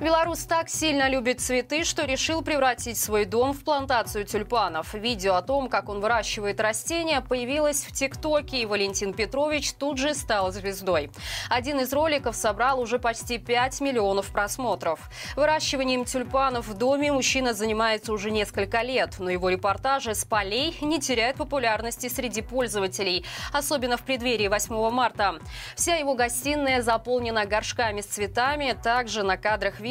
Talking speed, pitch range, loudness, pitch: 150 wpm, 215-275 Hz, -25 LUFS, 245 Hz